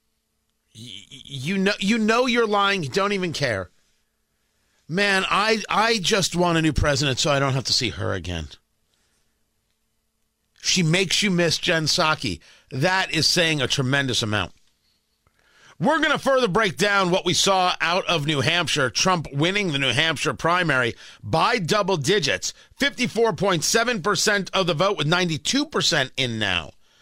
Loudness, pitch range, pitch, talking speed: -21 LUFS, 140-200 Hz, 175 Hz, 160 wpm